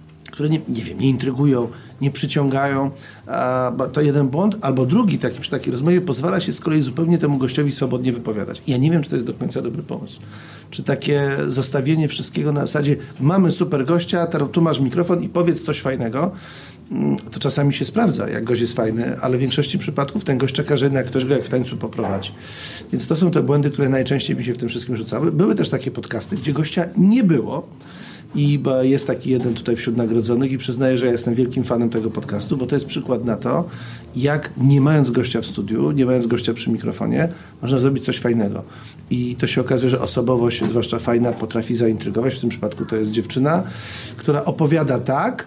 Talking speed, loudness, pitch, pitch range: 200 wpm, -19 LUFS, 135 Hz, 120-150 Hz